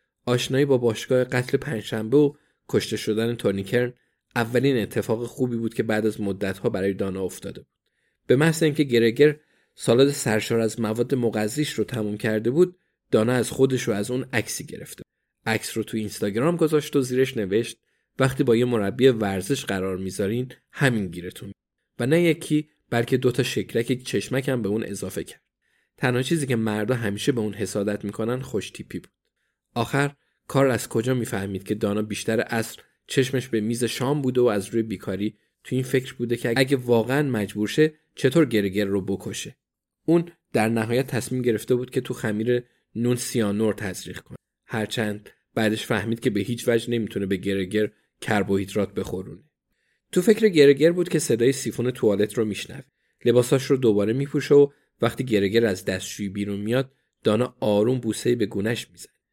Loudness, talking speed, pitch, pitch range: -24 LUFS, 165 wpm, 115 Hz, 105-130 Hz